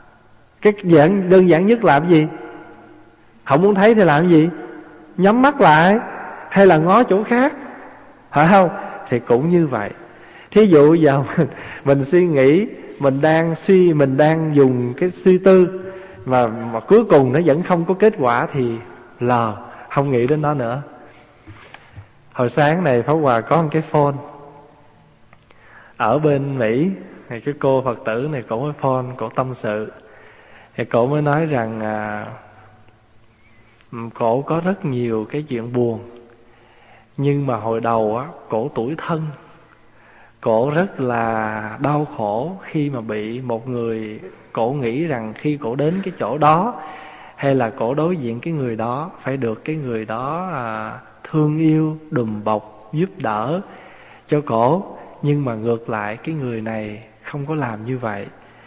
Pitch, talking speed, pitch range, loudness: 140 Hz, 160 wpm, 115-160 Hz, -17 LUFS